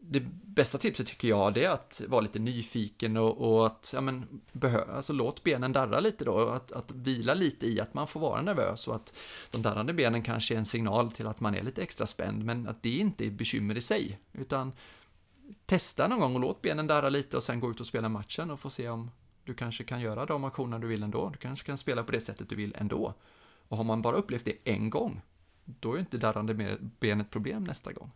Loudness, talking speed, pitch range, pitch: -32 LUFS, 240 wpm, 110-135 Hz, 115 Hz